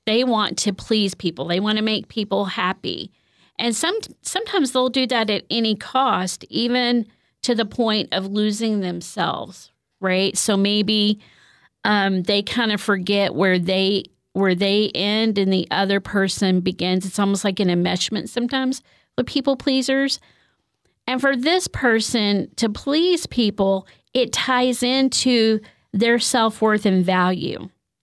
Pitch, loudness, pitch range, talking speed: 210 Hz, -20 LUFS, 195-240 Hz, 150 wpm